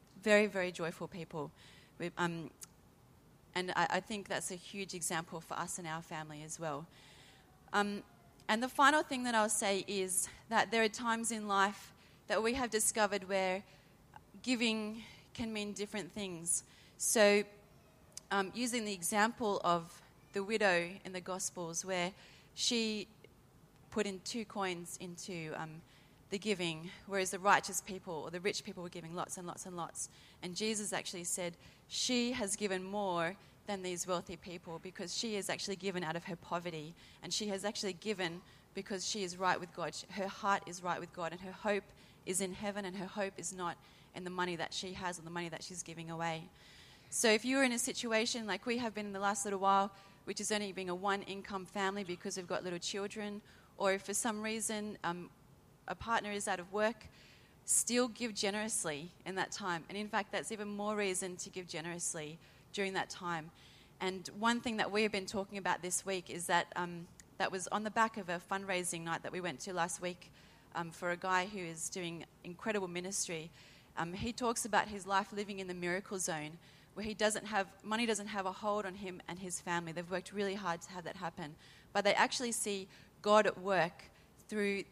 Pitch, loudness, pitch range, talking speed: 190 Hz, -37 LUFS, 175-205 Hz, 200 wpm